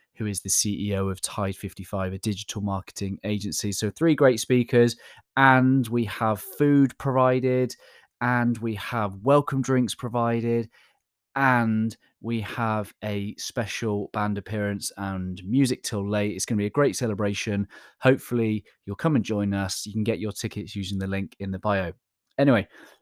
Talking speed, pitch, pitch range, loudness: 160 wpm, 105 Hz, 100-120 Hz, -25 LUFS